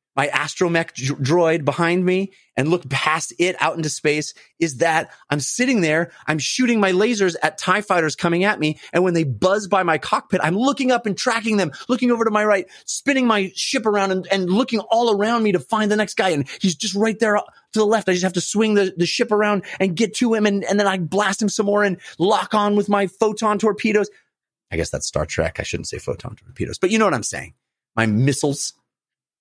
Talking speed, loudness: 235 wpm, -20 LUFS